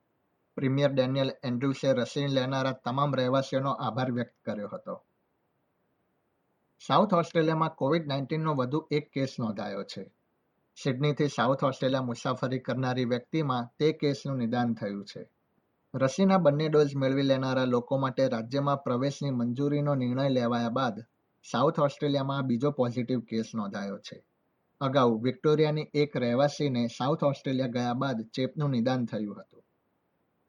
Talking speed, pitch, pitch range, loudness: 125 wpm, 135 Hz, 125-145 Hz, -29 LUFS